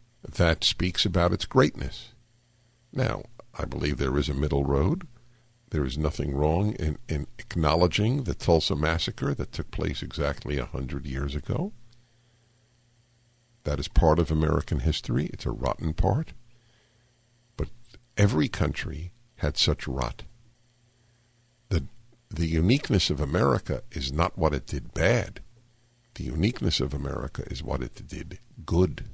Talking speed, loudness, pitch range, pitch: 140 wpm, -27 LUFS, 75-120 Hz, 90 Hz